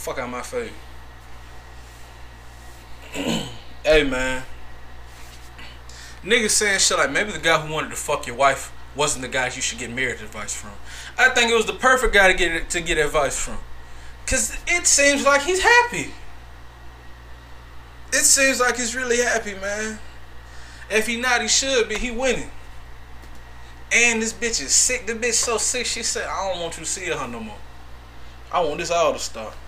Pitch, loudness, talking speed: 105 Hz, -20 LUFS, 180 wpm